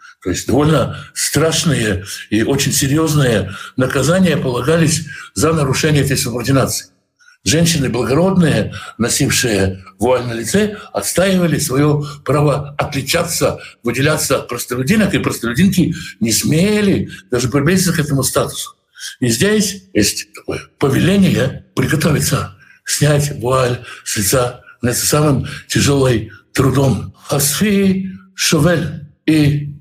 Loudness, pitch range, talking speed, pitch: -15 LUFS, 125-170 Hz, 105 wpm, 145 Hz